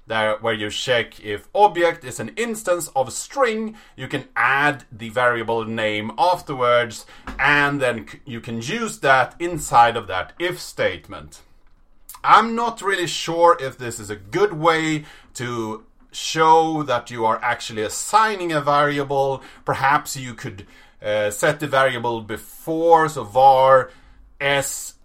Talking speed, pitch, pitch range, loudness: 140 wpm, 135 Hz, 115-160 Hz, -20 LUFS